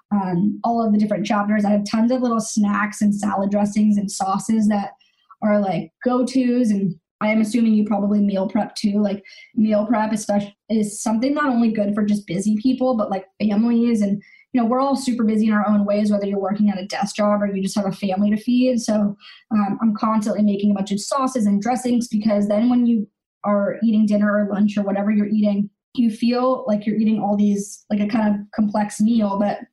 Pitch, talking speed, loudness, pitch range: 210 Hz, 225 wpm, -20 LUFS, 205-225 Hz